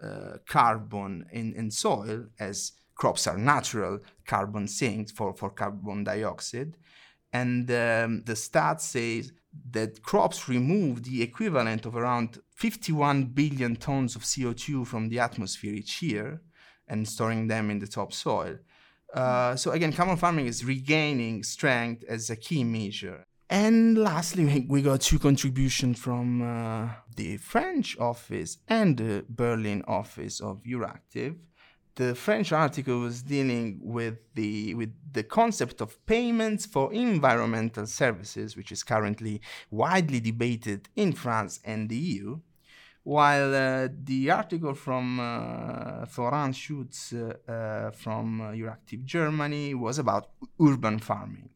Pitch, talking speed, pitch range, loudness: 120 Hz, 135 wpm, 110-145 Hz, -28 LUFS